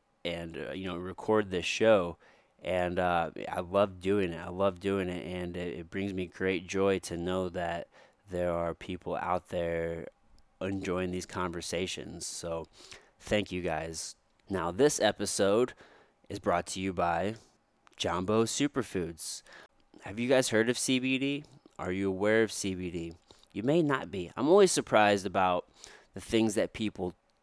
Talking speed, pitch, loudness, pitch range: 160 wpm, 95 Hz, -31 LUFS, 85-105 Hz